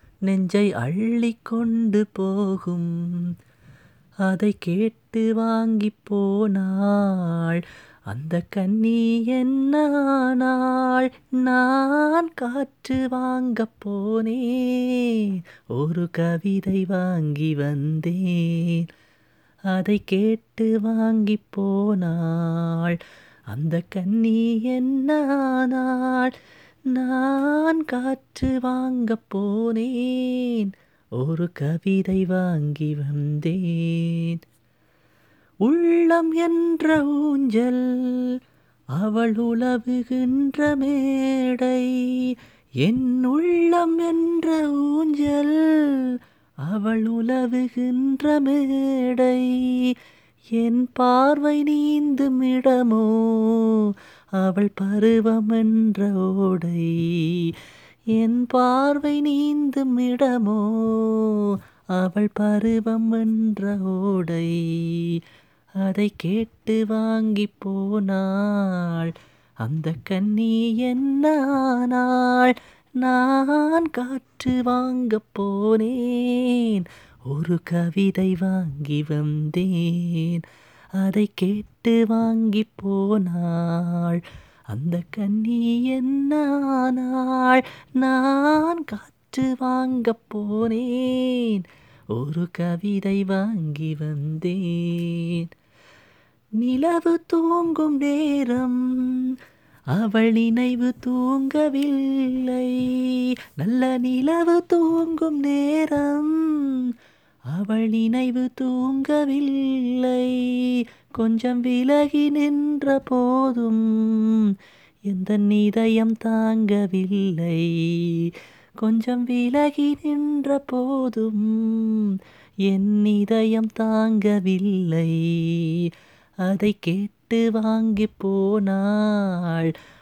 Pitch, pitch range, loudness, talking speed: 225 Hz, 190-255 Hz, -22 LUFS, 55 wpm